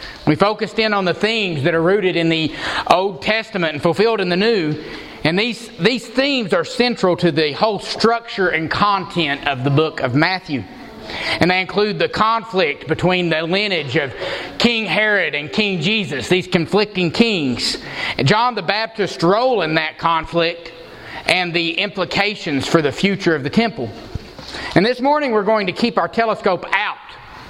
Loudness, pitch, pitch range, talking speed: -17 LUFS, 185 Hz, 165-215 Hz, 170 wpm